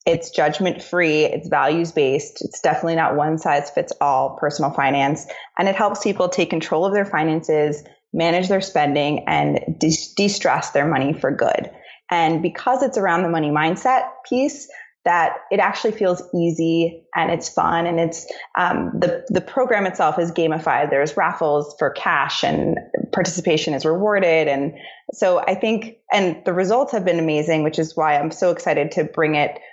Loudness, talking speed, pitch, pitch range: -20 LUFS, 175 wpm, 165 Hz, 155-195 Hz